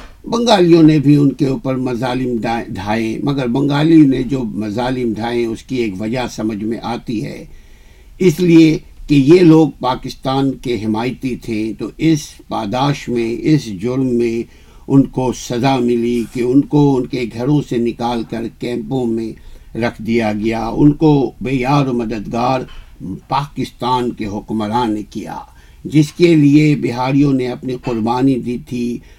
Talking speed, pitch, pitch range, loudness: 155 wpm, 125 Hz, 115-140 Hz, -15 LUFS